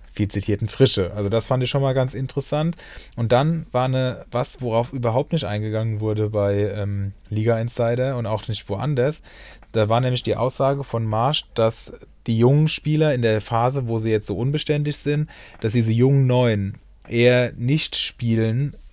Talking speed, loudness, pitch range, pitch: 180 wpm, -21 LUFS, 110-135 Hz, 120 Hz